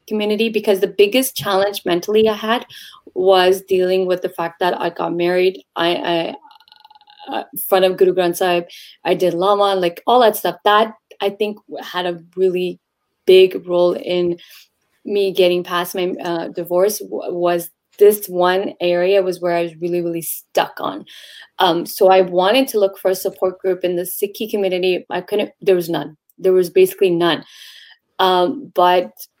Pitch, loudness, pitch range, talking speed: 185 Hz, -17 LUFS, 175-200 Hz, 175 wpm